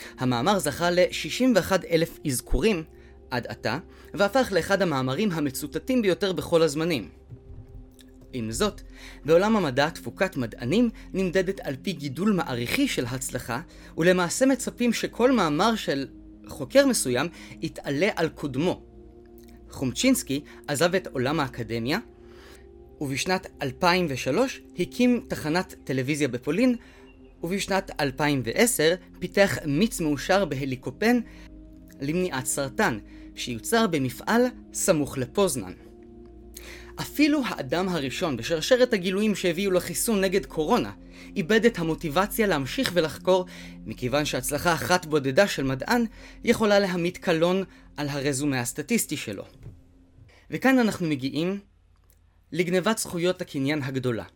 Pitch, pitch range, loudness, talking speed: 160 Hz, 130-195 Hz, -25 LUFS, 105 wpm